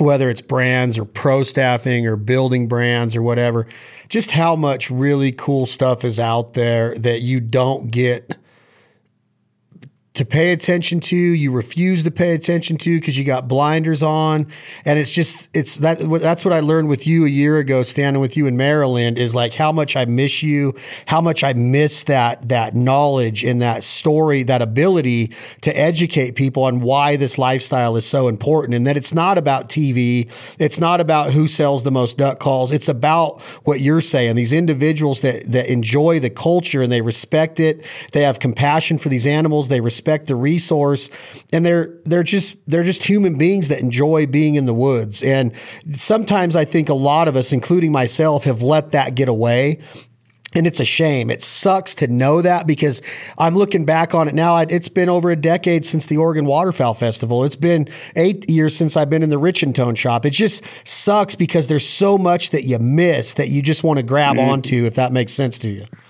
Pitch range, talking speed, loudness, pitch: 125-160 Hz, 200 wpm, -17 LUFS, 145 Hz